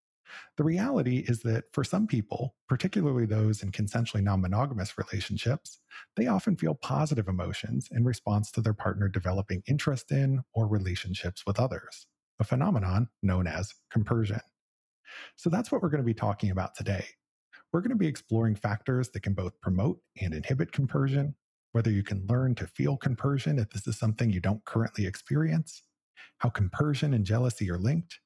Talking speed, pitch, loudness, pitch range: 170 wpm, 115 Hz, -30 LUFS, 100-135 Hz